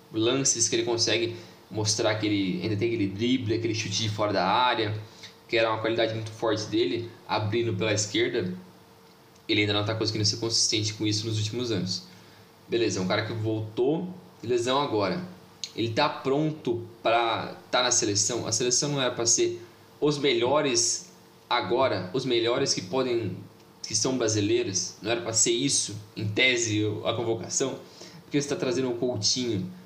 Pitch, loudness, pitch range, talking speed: 115 Hz, -26 LUFS, 105-125 Hz, 175 wpm